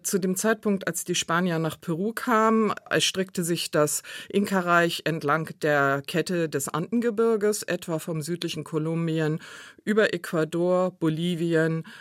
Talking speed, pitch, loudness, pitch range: 125 wpm, 170 Hz, -25 LUFS, 160-195 Hz